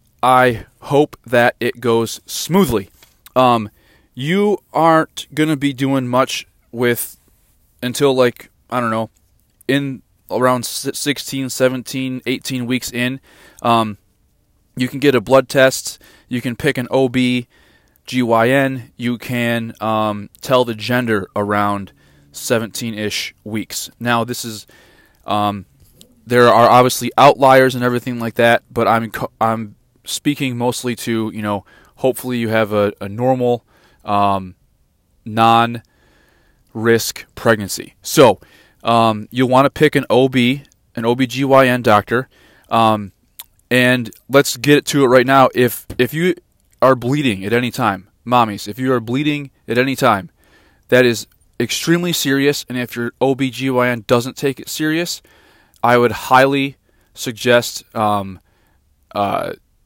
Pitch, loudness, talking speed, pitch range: 120 Hz, -16 LUFS, 130 wpm, 110-130 Hz